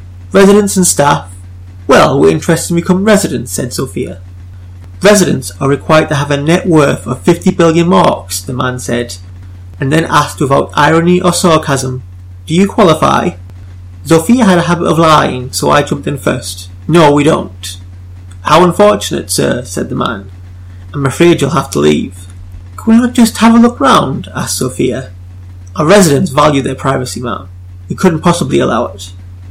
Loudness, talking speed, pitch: -10 LUFS, 170 wpm, 135 Hz